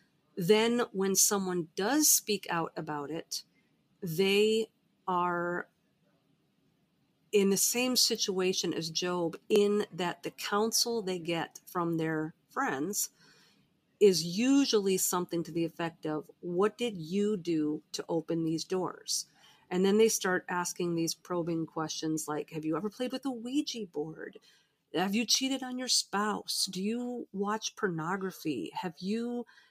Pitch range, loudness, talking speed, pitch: 170-215 Hz, -31 LUFS, 140 wpm, 185 Hz